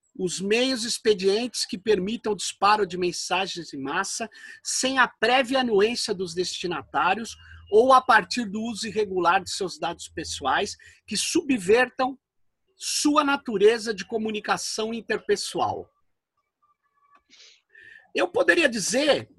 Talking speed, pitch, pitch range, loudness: 115 wpm, 230 Hz, 200-270 Hz, -24 LUFS